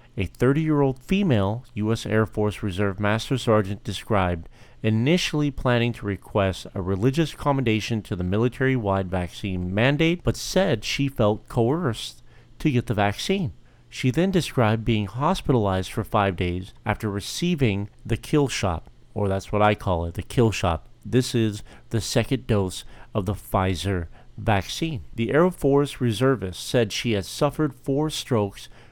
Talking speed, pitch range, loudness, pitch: 155 wpm, 100-130 Hz, -24 LUFS, 115 Hz